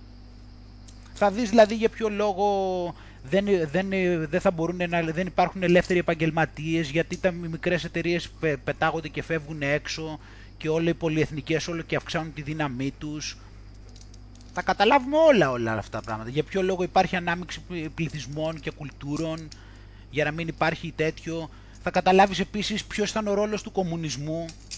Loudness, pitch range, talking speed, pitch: -26 LUFS, 145-180 Hz, 155 wpm, 165 Hz